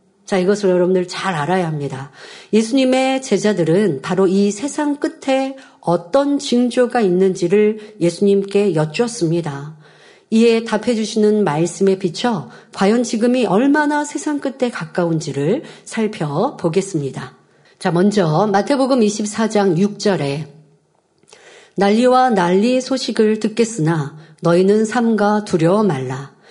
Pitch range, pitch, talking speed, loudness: 175-240 Hz, 205 Hz, 265 characters per minute, -17 LUFS